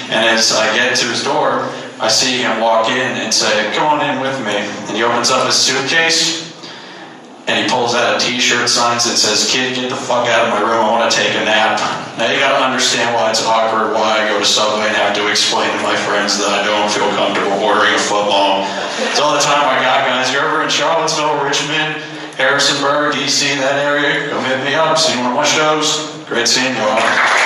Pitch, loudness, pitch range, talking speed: 125 Hz, -13 LUFS, 110-145 Hz, 225 wpm